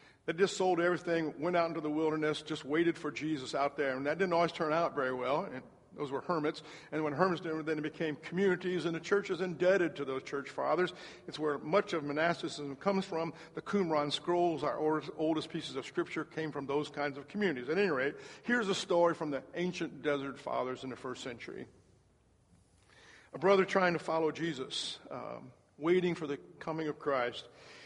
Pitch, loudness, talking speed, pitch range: 160 Hz, -34 LUFS, 200 wpm, 150-175 Hz